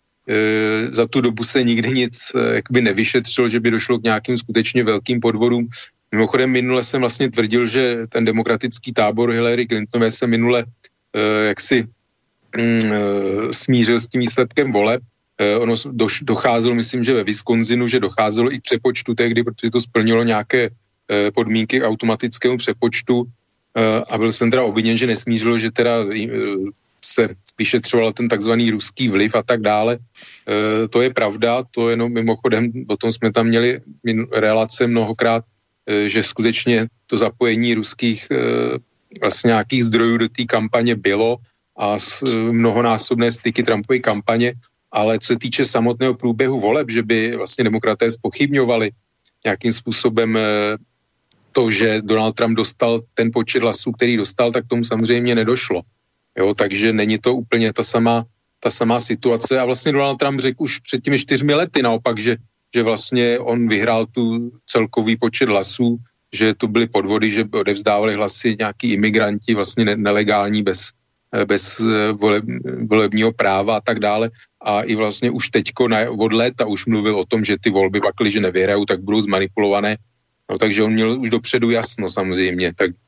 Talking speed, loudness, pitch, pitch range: 160 wpm, -18 LUFS, 115 Hz, 110-120 Hz